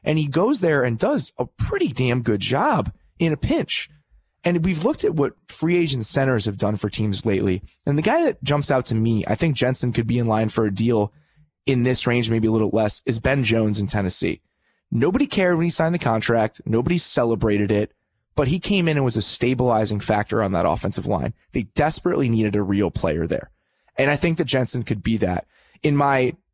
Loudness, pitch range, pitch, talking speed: -21 LUFS, 105-145 Hz, 120 Hz, 220 wpm